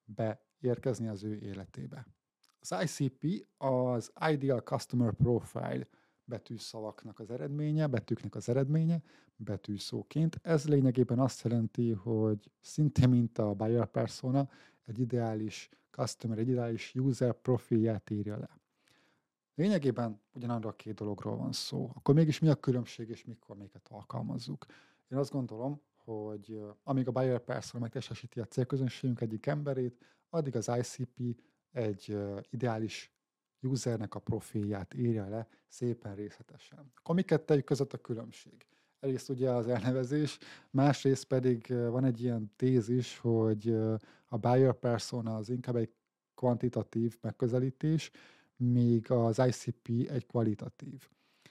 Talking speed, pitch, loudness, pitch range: 120 wpm, 120 Hz, -33 LUFS, 110-135 Hz